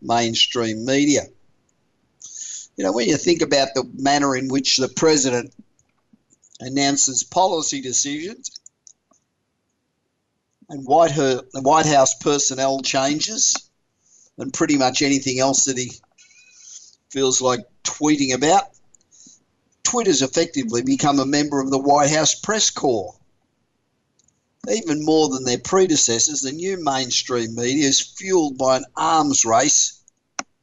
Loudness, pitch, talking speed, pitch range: -18 LUFS, 140 Hz, 120 wpm, 130-155 Hz